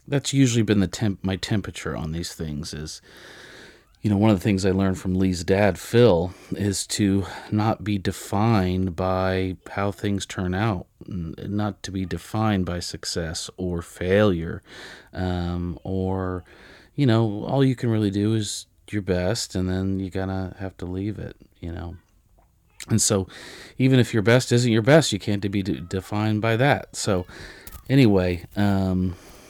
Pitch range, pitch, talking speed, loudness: 90-105 Hz, 95 Hz, 170 wpm, -23 LUFS